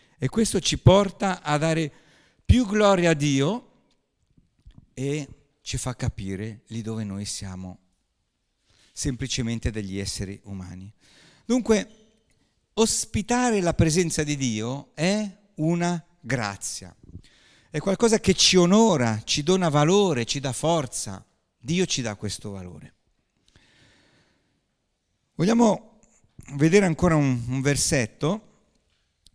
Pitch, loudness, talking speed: 140 Hz, -23 LUFS, 110 wpm